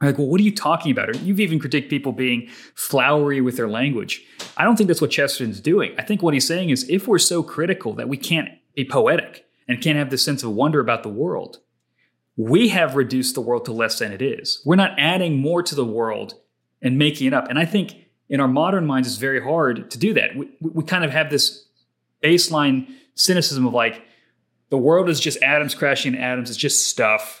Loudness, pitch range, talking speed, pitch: -19 LUFS, 130-165 Hz, 230 wpm, 145 Hz